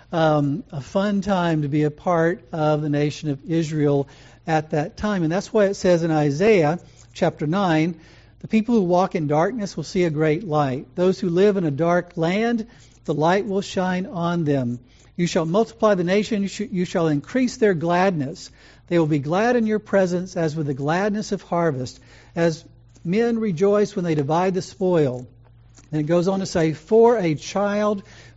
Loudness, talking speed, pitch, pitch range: -21 LUFS, 195 wpm, 170 Hz, 150-195 Hz